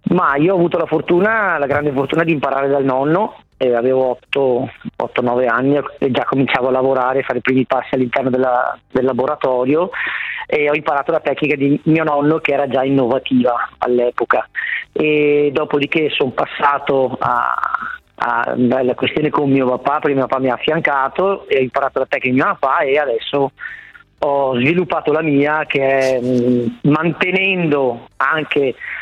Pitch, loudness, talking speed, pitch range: 140 Hz, -16 LUFS, 160 wpm, 130-155 Hz